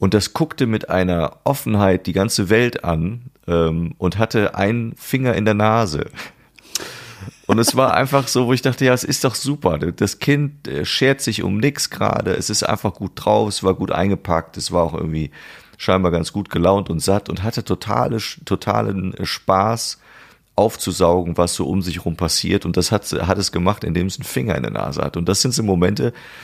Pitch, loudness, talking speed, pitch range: 100 Hz, -19 LUFS, 200 wpm, 90-115 Hz